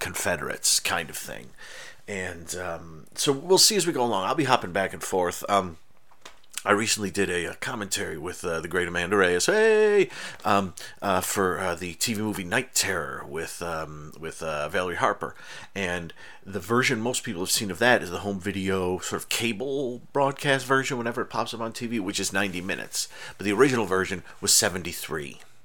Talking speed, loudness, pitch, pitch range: 195 wpm, -25 LUFS, 100 Hz, 90-120 Hz